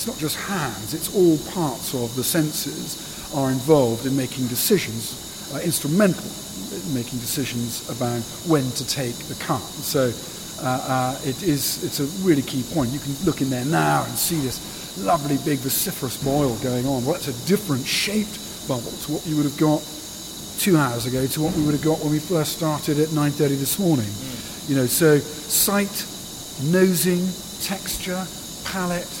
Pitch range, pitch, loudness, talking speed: 130-175 Hz, 150 Hz, -23 LUFS, 180 wpm